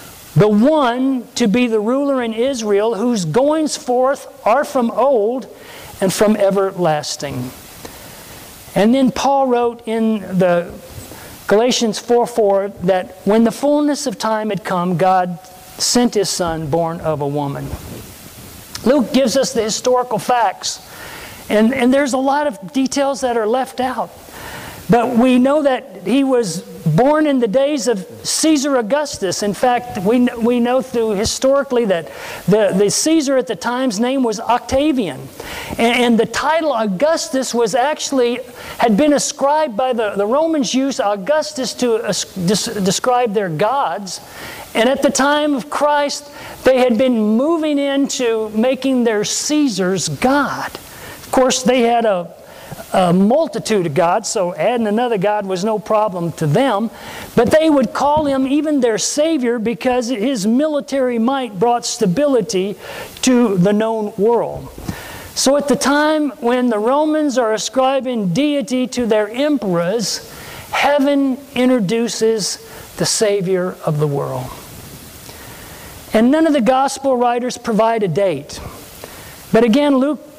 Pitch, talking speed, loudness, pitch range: 240 Hz, 145 wpm, -16 LUFS, 210-270 Hz